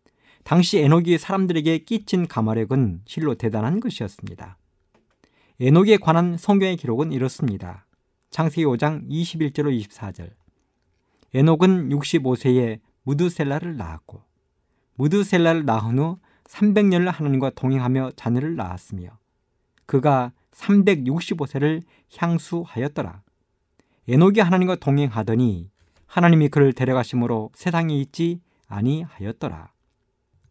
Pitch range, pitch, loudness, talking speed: 110-170 Hz, 140 Hz, -21 LUFS, 260 characters per minute